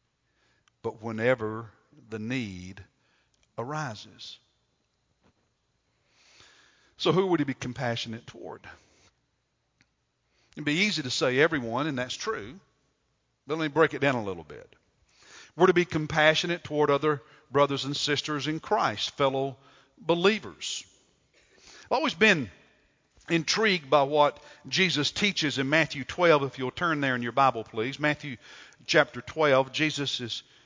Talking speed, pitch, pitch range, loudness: 130 wpm, 145 Hz, 125-155 Hz, -26 LUFS